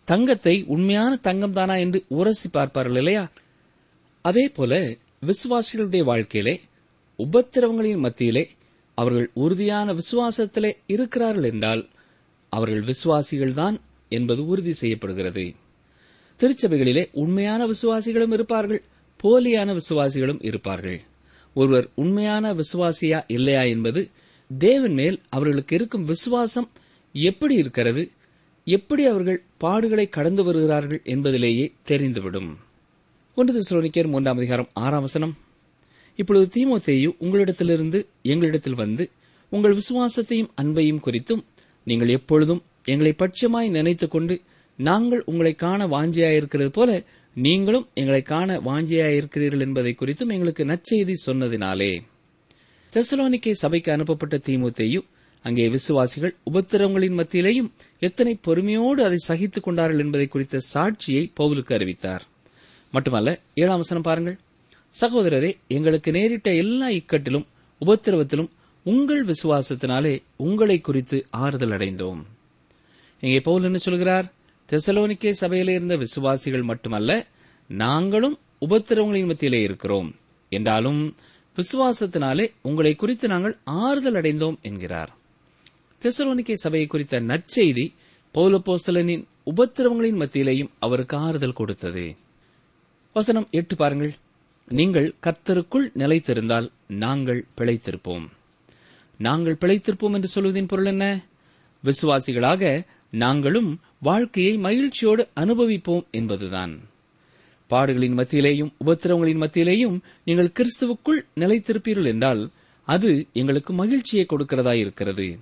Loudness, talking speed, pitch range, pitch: -22 LUFS, 90 wpm, 135-200 Hz, 165 Hz